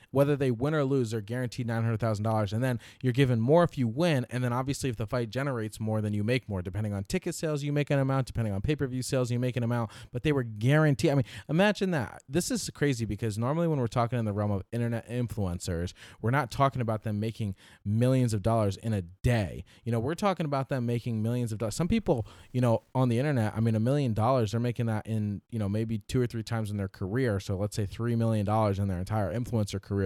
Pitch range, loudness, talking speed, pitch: 110-135 Hz, -29 LUFS, 250 wpm, 120 Hz